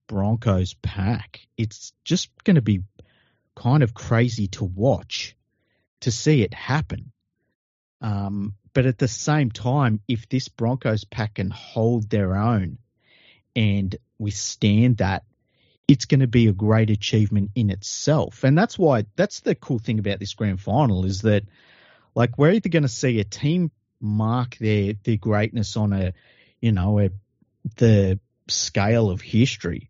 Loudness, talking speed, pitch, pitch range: -22 LUFS, 155 wpm, 110 Hz, 105-125 Hz